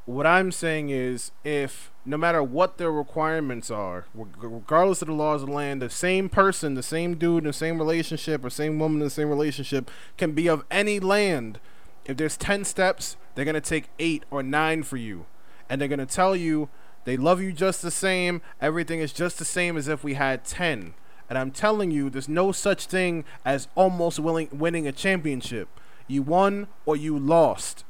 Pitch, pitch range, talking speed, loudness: 155 Hz, 140-175 Hz, 195 wpm, -25 LUFS